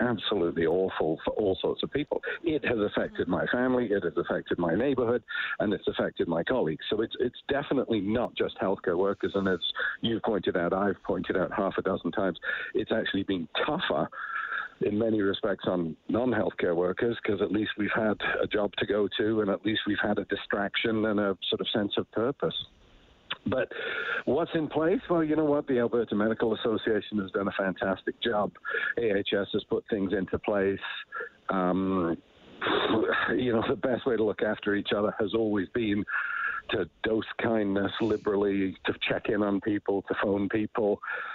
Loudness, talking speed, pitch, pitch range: -29 LUFS, 180 wpm, 105 Hz, 100-120 Hz